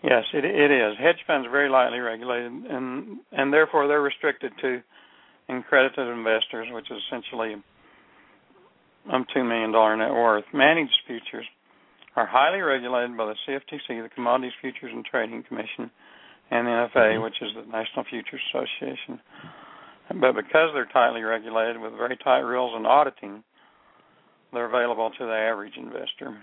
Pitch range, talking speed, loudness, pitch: 115-130 Hz, 150 wpm, -24 LUFS, 120 Hz